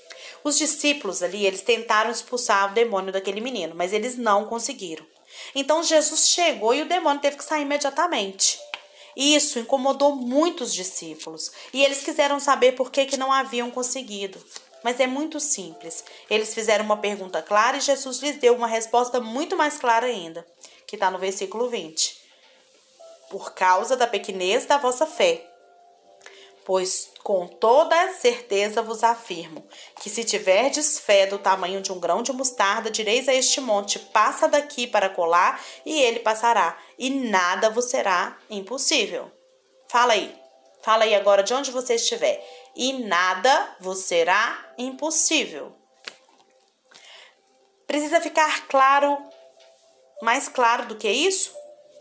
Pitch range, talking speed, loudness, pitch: 200-285 Hz, 145 wpm, -21 LUFS, 240 Hz